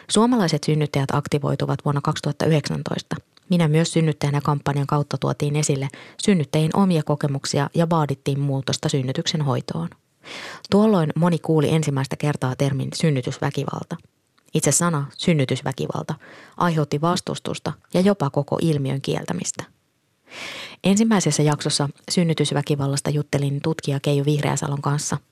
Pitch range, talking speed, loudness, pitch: 140-165 Hz, 105 wpm, -22 LUFS, 150 Hz